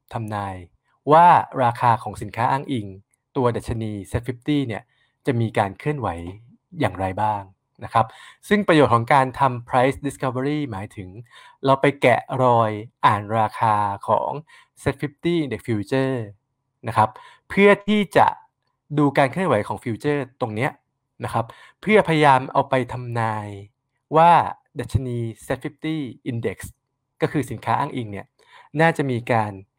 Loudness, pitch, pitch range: -21 LUFS, 125 Hz, 110-140 Hz